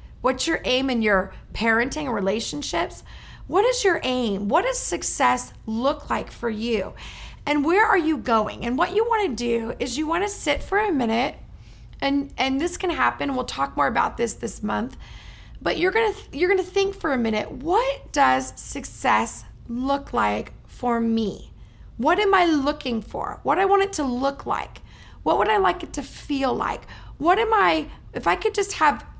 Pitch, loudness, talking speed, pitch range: 280 Hz, -23 LUFS, 200 wpm, 235-375 Hz